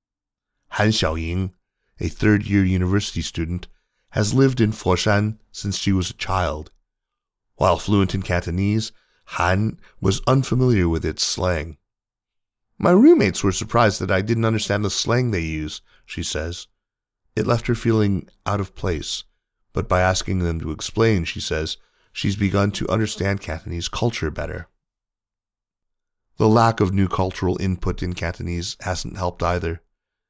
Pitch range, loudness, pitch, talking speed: 90-110 Hz, -21 LUFS, 95 Hz, 145 wpm